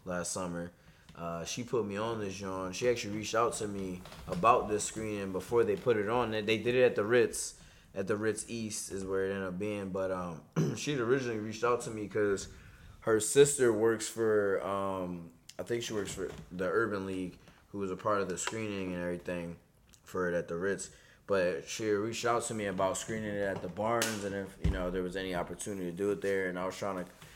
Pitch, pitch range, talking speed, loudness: 100 Hz, 90-110 Hz, 230 wpm, -33 LUFS